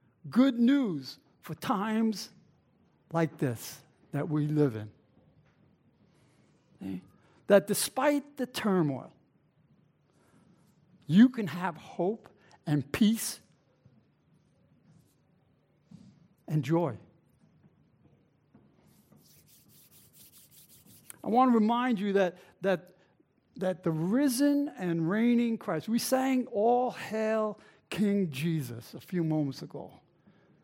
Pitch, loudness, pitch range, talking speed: 185 Hz, -29 LUFS, 155-225 Hz, 90 wpm